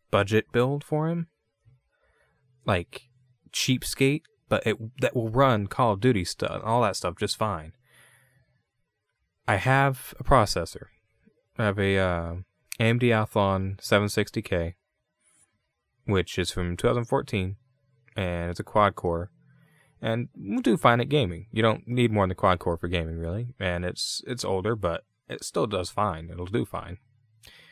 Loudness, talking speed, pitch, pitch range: -26 LUFS, 150 wpm, 110 Hz, 95-125 Hz